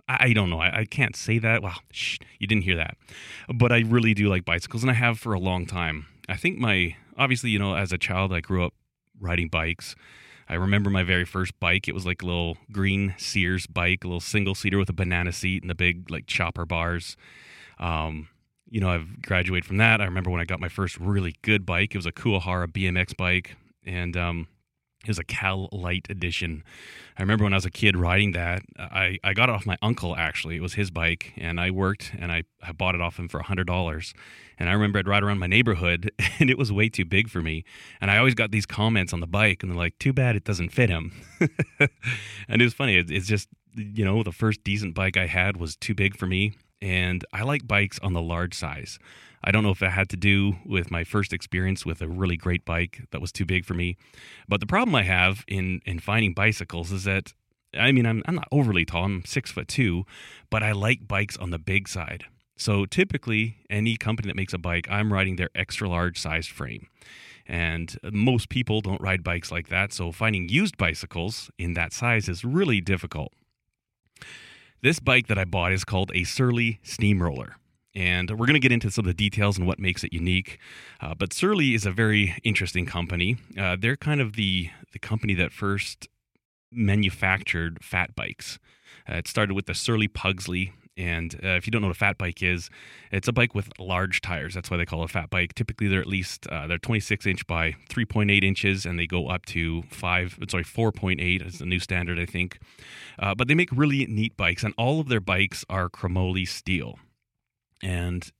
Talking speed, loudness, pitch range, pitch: 220 wpm, -25 LUFS, 90-110 Hz, 95 Hz